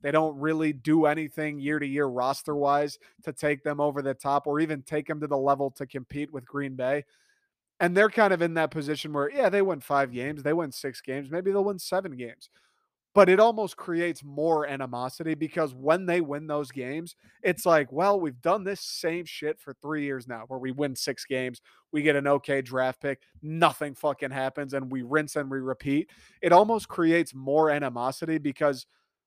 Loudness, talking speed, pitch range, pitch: -27 LUFS, 205 wpm, 140-165 Hz, 150 Hz